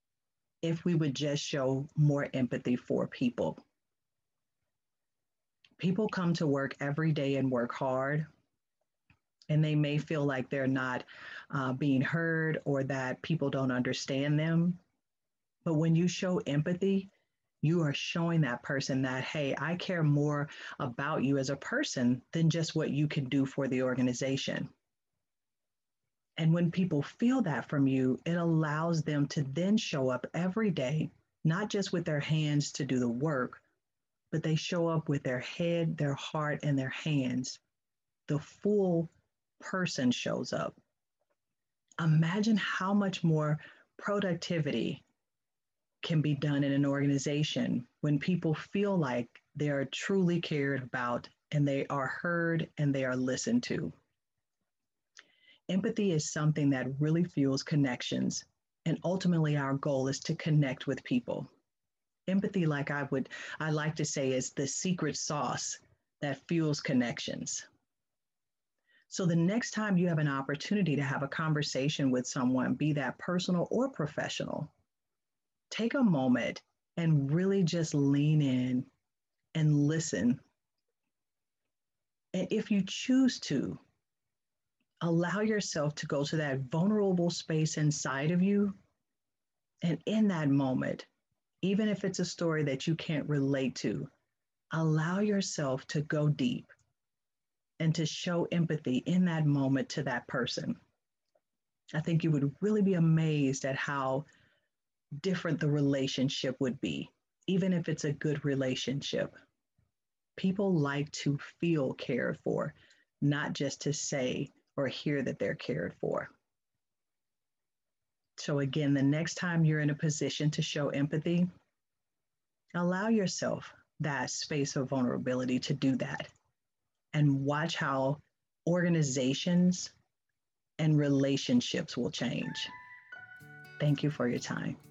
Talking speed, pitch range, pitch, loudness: 135 wpm, 135-170 Hz, 150 Hz, -32 LUFS